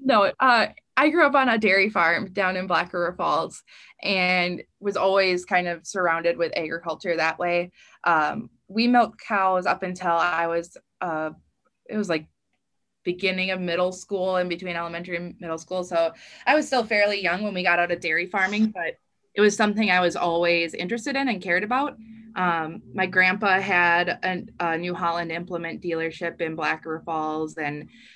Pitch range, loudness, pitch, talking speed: 170-200 Hz, -23 LUFS, 180 Hz, 185 wpm